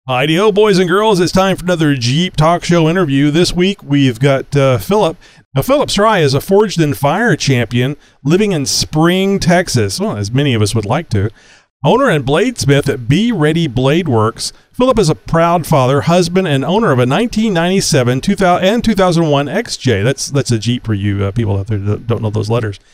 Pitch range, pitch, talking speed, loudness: 125-180 Hz, 145 Hz, 205 wpm, -13 LUFS